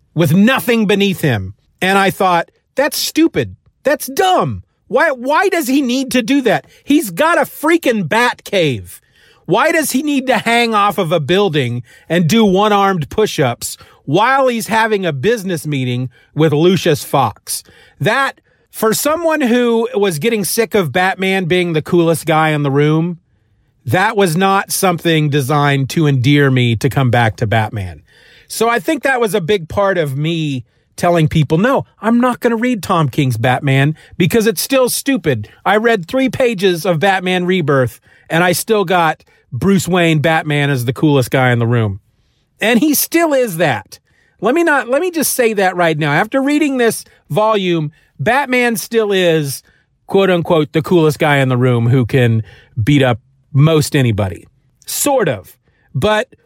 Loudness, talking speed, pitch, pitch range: -14 LUFS, 175 wpm, 180 Hz, 145-230 Hz